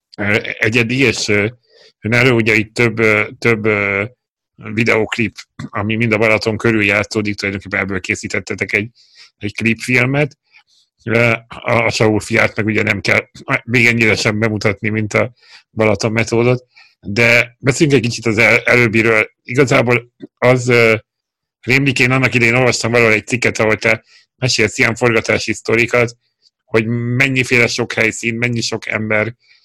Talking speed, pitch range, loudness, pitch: 140 wpm, 110-120 Hz, -14 LUFS, 115 Hz